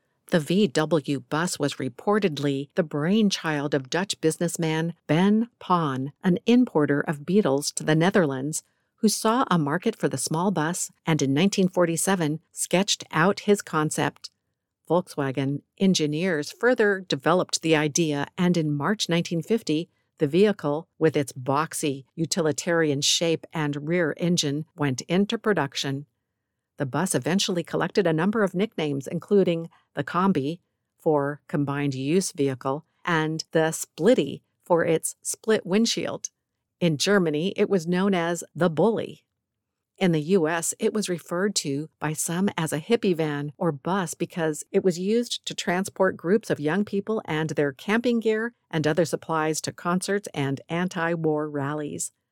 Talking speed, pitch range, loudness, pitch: 145 wpm, 150-190 Hz, -25 LUFS, 165 Hz